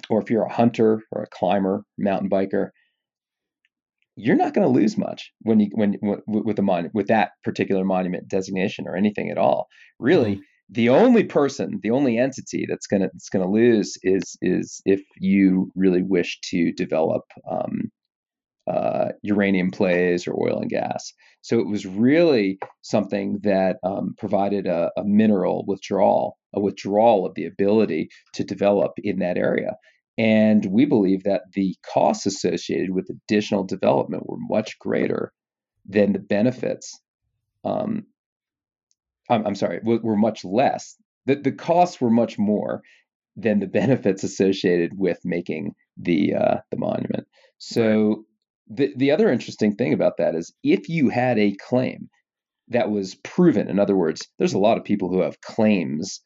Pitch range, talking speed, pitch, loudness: 95-110 Hz, 160 wpm, 100 Hz, -22 LUFS